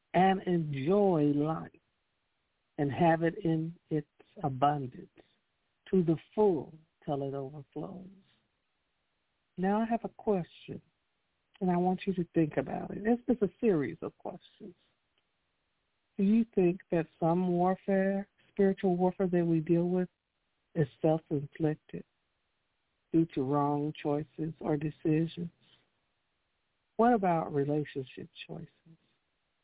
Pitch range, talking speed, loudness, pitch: 150-185 Hz, 115 wpm, -31 LUFS, 165 Hz